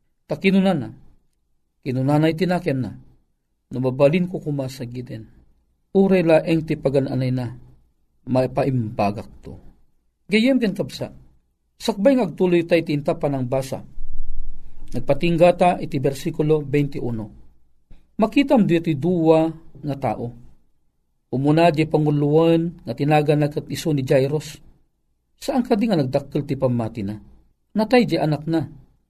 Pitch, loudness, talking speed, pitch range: 145 Hz, -20 LUFS, 120 wpm, 125-170 Hz